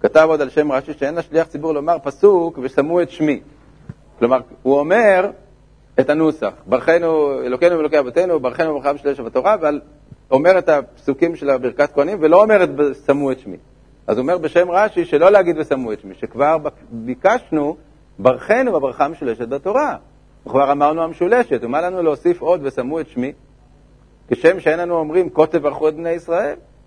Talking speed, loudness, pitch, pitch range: 170 wpm, -17 LUFS, 150 Hz, 140-170 Hz